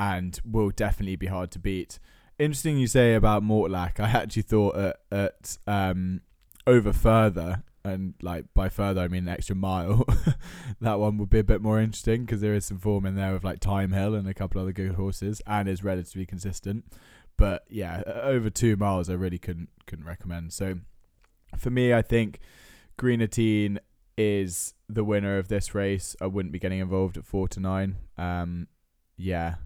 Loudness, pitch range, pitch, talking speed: -27 LUFS, 95-105 Hz, 100 Hz, 185 wpm